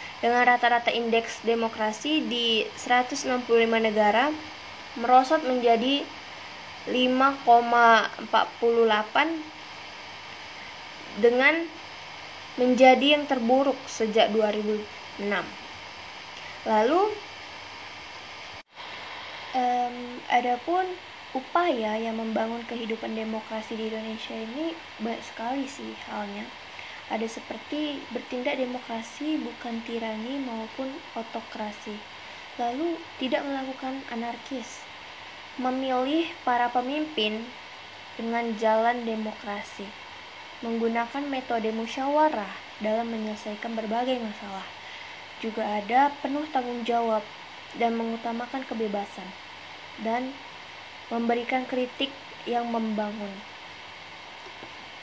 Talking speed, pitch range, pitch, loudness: 75 wpm, 225-265 Hz, 240 Hz, -26 LUFS